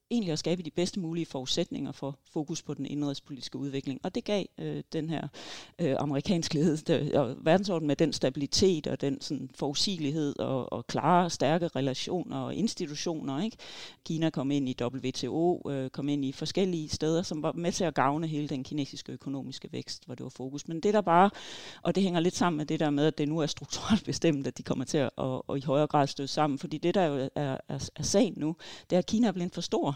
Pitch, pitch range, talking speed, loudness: 155 Hz, 140-170 Hz, 225 wpm, -30 LUFS